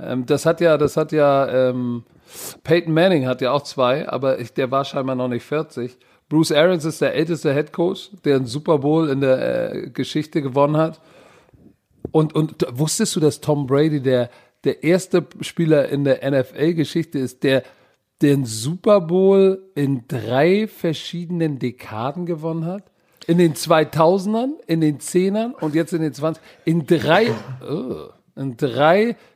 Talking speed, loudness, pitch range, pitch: 165 wpm, -19 LUFS, 135-170 Hz, 155 Hz